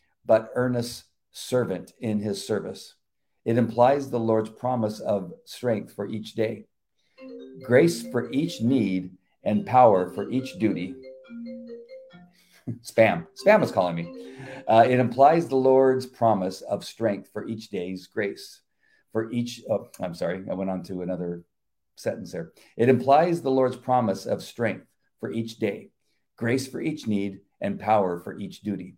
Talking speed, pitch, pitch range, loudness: 150 wpm, 115 Hz, 95-130 Hz, -25 LUFS